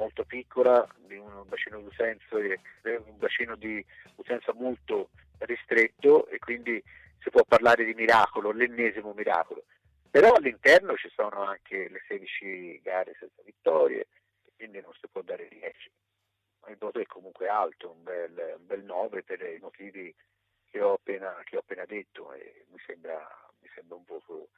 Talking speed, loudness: 150 wpm, -27 LUFS